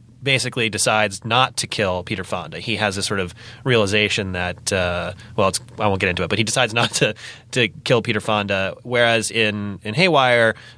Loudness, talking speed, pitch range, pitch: -19 LUFS, 195 wpm, 100-120 Hz, 110 Hz